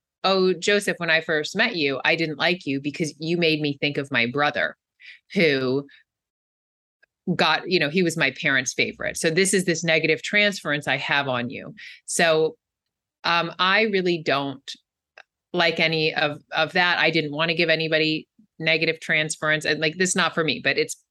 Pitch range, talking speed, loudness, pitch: 150-175 Hz, 185 wpm, -22 LUFS, 160 Hz